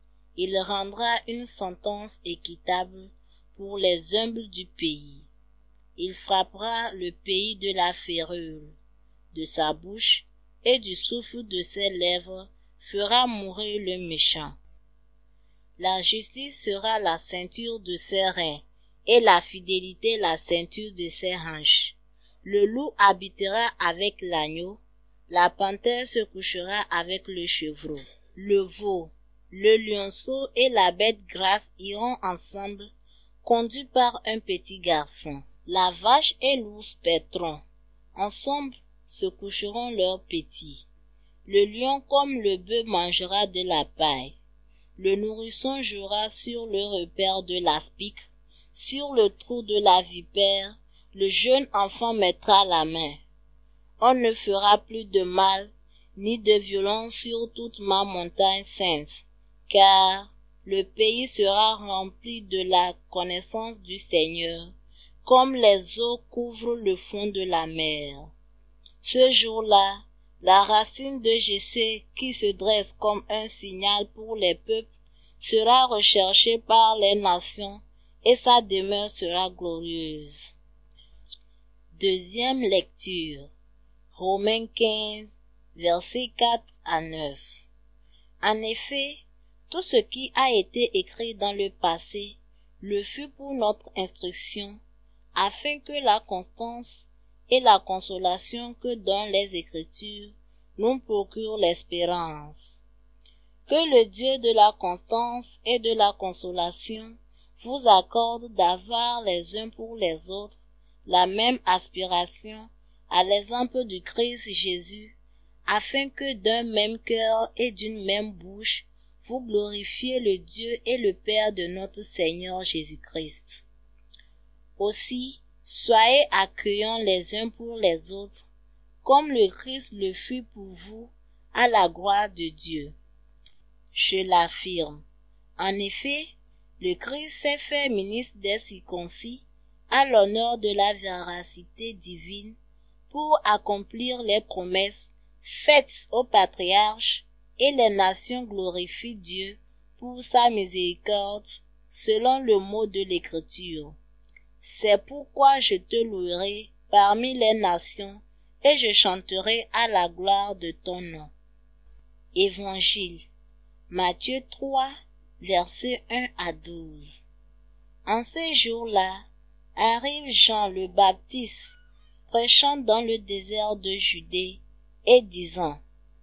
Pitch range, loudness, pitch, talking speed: 180-230 Hz, -24 LUFS, 200 Hz, 120 wpm